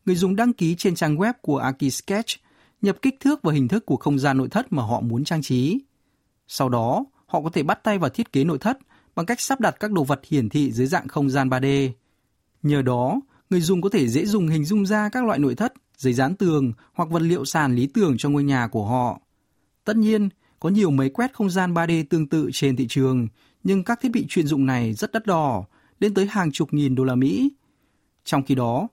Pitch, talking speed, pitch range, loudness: 160 Hz, 240 wpm, 135-205 Hz, -22 LUFS